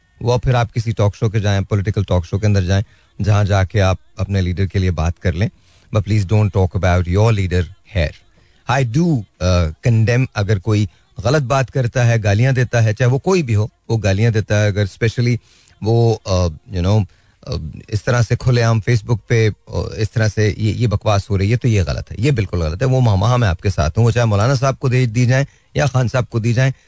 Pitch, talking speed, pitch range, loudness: 110 Hz, 230 wpm, 95-120 Hz, -17 LUFS